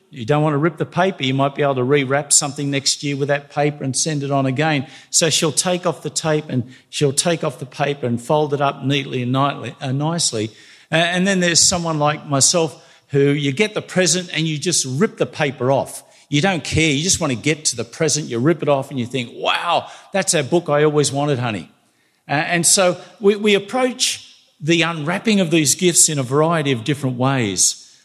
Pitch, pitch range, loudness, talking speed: 150 Hz, 135-170 Hz, -18 LUFS, 220 wpm